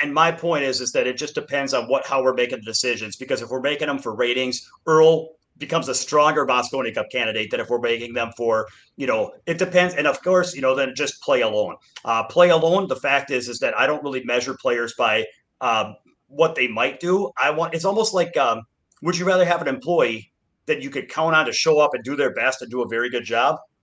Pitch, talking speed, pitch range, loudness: 140 Hz, 245 wpm, 125-165 Hz, -21 LUFS